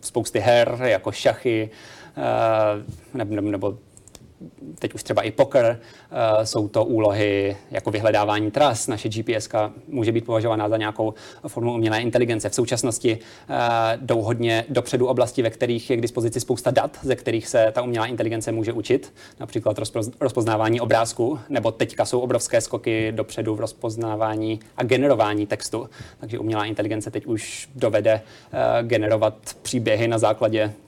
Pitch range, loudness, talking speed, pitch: 110-120 Hz, -22 LUFS, 145 wpm, 110 Hz